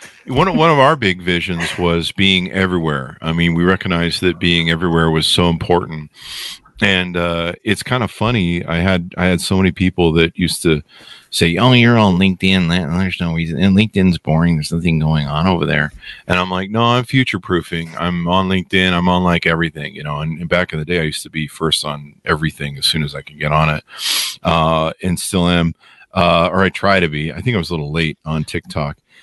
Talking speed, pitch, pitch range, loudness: 220 wpm, 85 Hz, 80-95 Hz, -16 LUFS